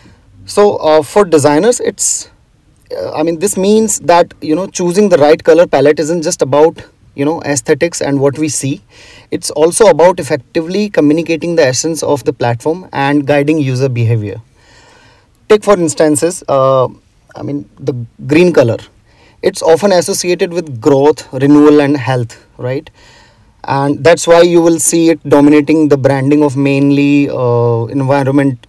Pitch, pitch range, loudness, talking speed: 150 Hz, 135-165 Hz, -10 LUFS, 155 wpm